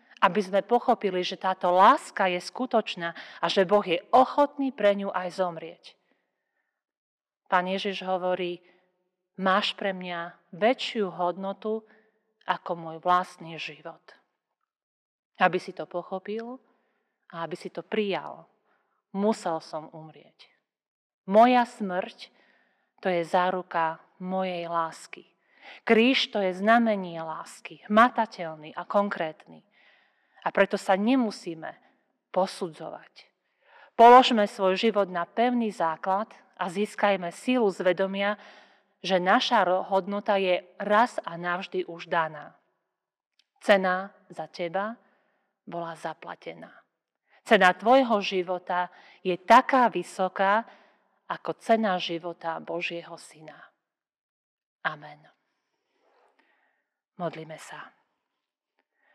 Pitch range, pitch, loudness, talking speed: 175-210 Hz, 190 Hz, -26 LUFS, 100 wpm